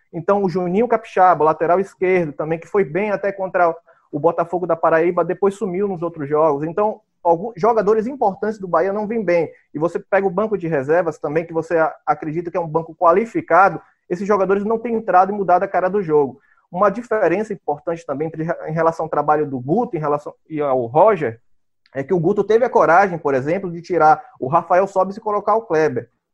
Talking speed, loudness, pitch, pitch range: 205 wpm, -18 LUFS, 180 Hz, 160-200 Hz